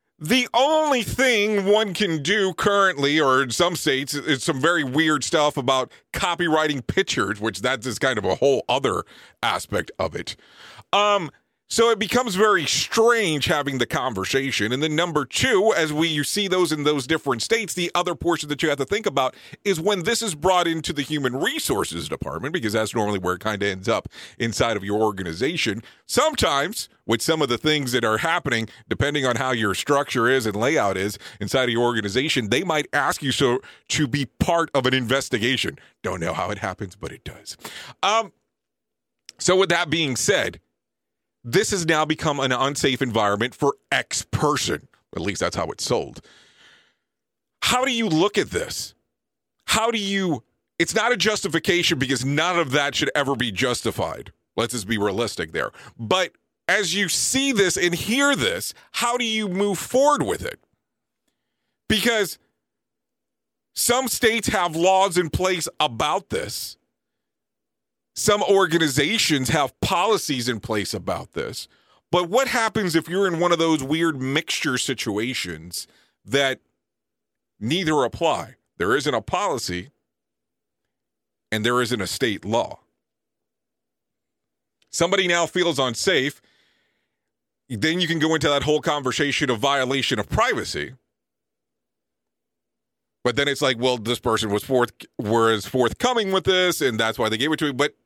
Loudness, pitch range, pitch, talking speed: -22 LUFS, 120-185 Hz, 145 Hz, 165 wpm